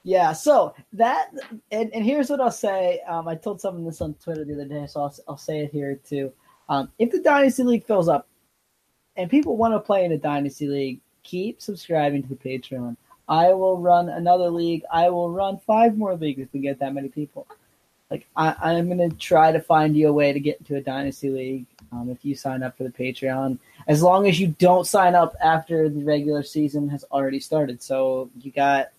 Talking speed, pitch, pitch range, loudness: 220 wpm, 155 Hz, 140-185 Hz, -22 LUFS